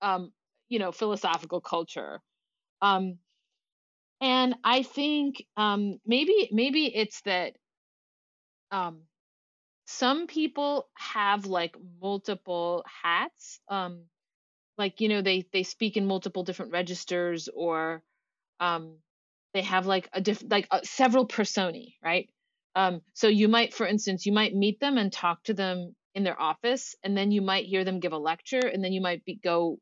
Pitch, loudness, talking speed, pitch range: 195 Hz, -28 LUFS, 155 wpm, 180-225 Hz